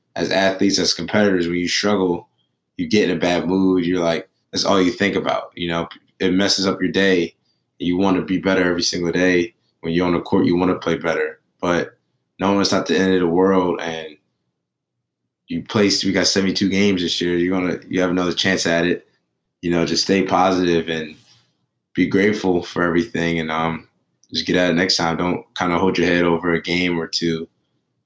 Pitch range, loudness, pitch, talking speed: 85-95 Hz, -19 LUFS, 90 Hz, 215 wpm